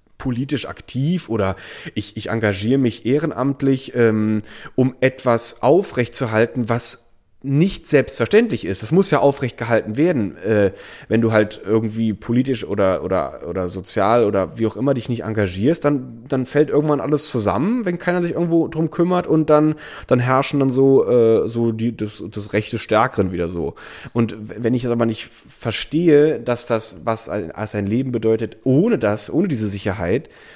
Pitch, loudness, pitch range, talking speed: 120 Hz, -19 LUFS, 110-140 Hz, 165 wpm